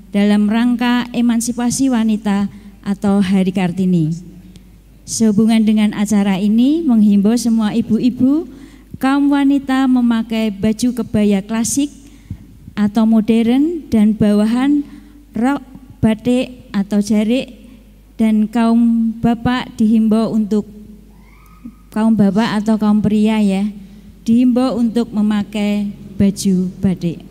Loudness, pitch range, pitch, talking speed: -15 LUFS, 205-245 Hz, 220 Hz, 95 wpm